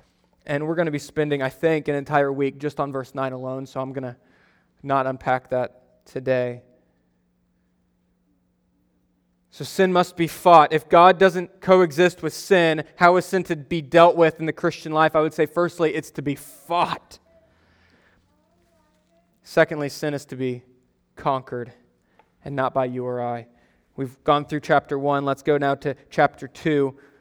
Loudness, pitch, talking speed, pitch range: -21 LUFS, 140 Hz, 170 wpm, 125-160 Hz